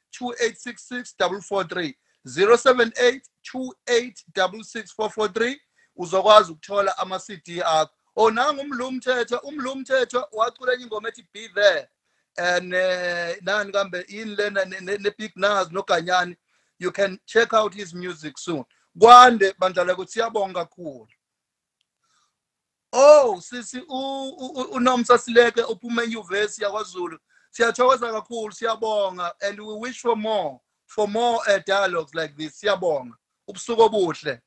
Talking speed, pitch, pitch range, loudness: 95 wpm, 215 Hz, 190-245 Hz, -21 LUFS